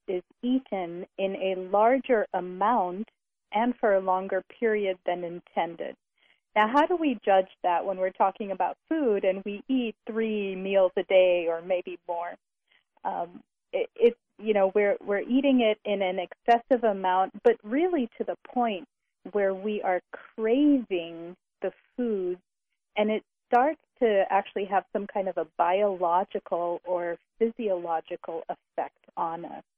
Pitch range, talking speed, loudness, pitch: 185-230 Hz, 150 wpm, -27 LUFS, 200 Hz